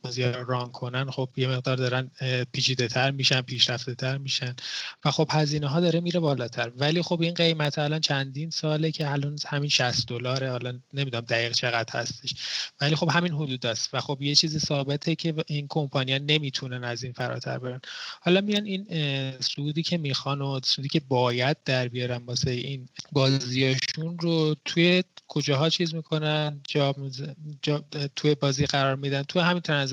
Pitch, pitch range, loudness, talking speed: 140 Hz, 130-155 Hz, -26 LUFS, 165 wpm